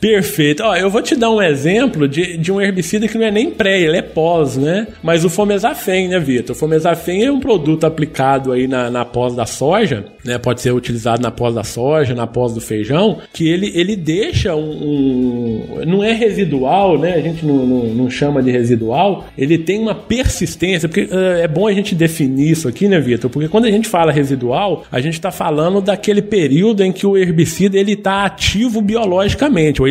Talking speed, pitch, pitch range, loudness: 210 wpm, 165 Hz, 135-200 Hz, -15 LUFS